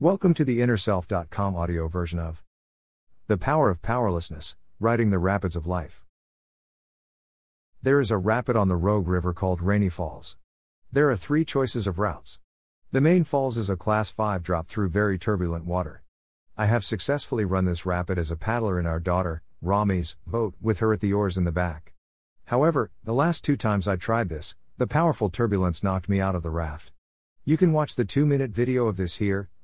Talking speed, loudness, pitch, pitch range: 190 wpm, -25 LUFS, 100 Hz, 85-115 Hz